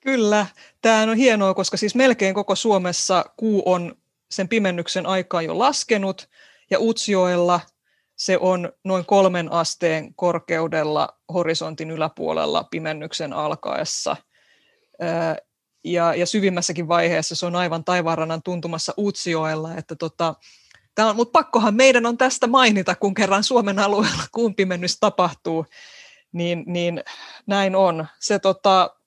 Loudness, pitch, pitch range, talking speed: -20 LUFS, 185 Hz, 170-210 Hz, 120 wpm